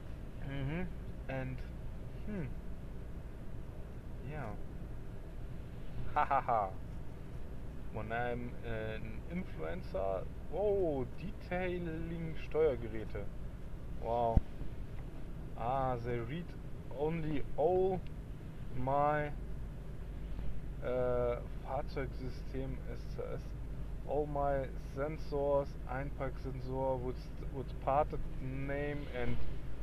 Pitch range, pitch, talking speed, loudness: 120-145 Hz, 135 Hz, 65 wpm, -39 LUFS